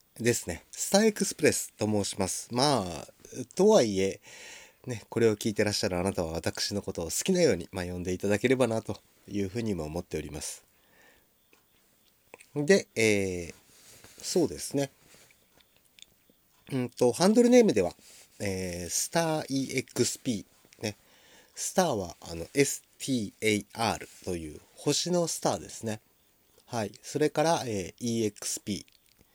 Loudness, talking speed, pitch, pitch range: -29 LUFS, 280 characters per minute, 110 Hz, 95-140 Hz